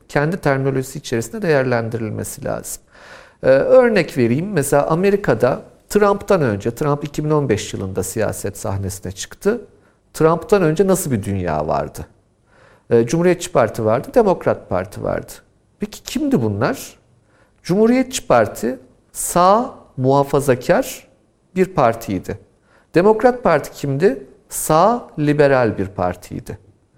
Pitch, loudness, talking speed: 145 Hz, -18 LUFS, 105 wpm